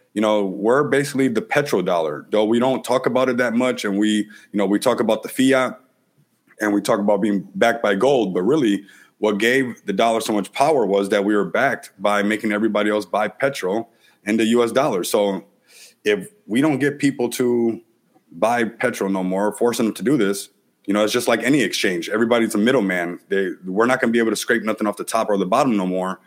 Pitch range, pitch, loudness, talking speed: 105-120 Hz, 110 Hz, -20 LUFS, 230 wpm